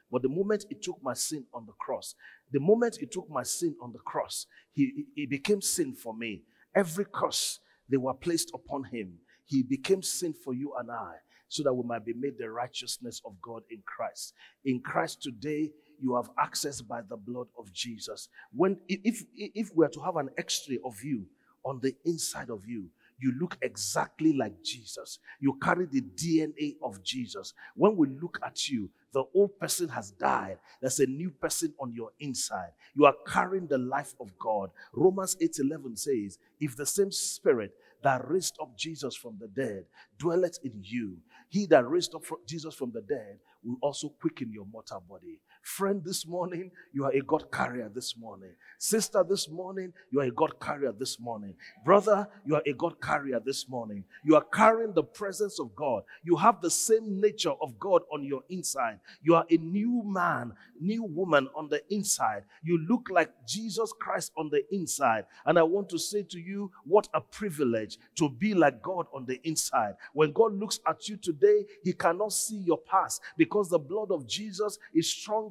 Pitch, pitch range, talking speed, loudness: 165 Hz, 135-200 Hz, 195 wpm, -30 LUFS